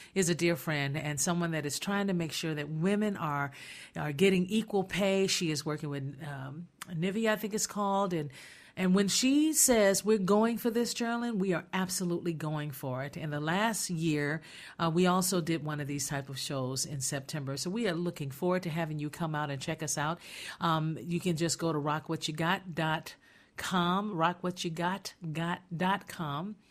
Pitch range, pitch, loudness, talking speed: 150-195 Hz, 170 Hz, -31 LUFS, 185 wpm